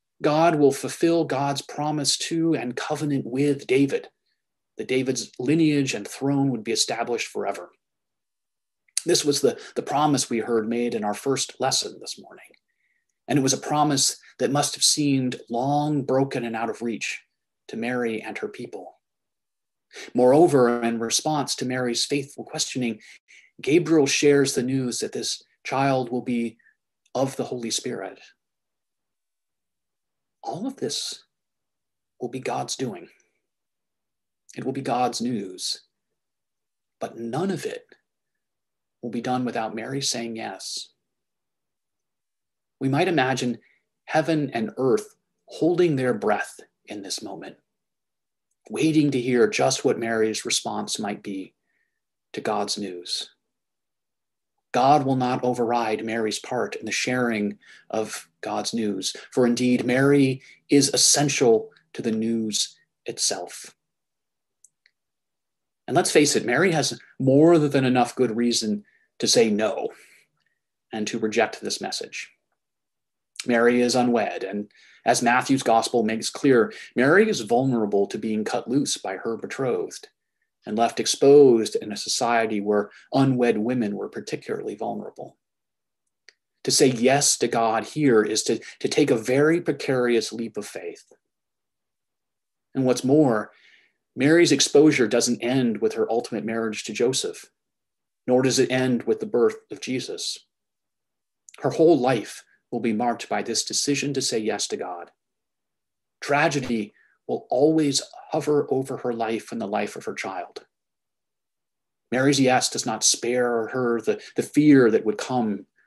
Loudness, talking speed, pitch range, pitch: -23 LUFS, 140 wpm, 115-145 Hz, 130 Hz